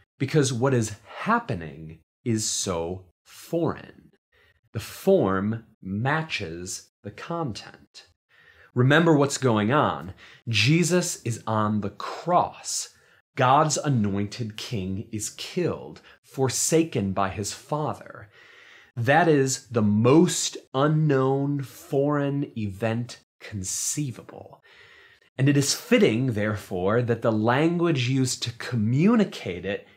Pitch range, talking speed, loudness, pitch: 105-145 Hz, 100 wpm, -24 LUFS, 120 Hz